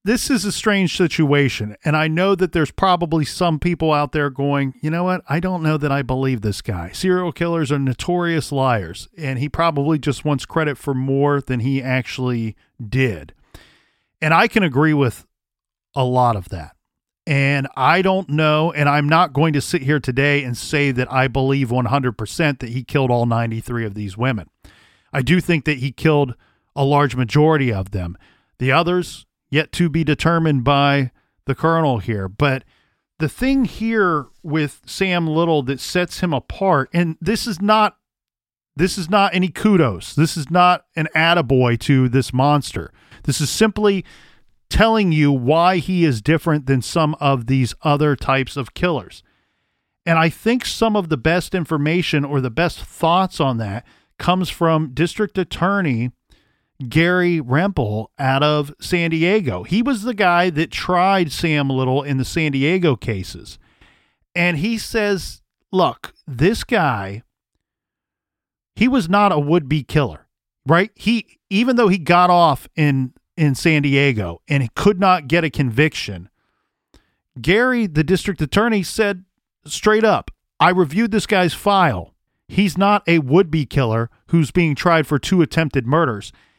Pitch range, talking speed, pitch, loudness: 130-180 Hz, 165 wpm, 150 Hz, -18 LUFS